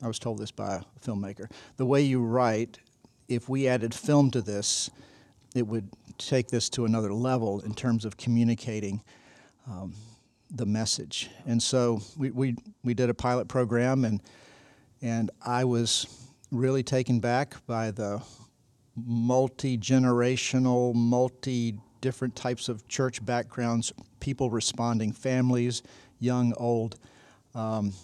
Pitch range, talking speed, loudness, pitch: 115-130 Hz, 135 wpm, -28 LUFS, 120 Hz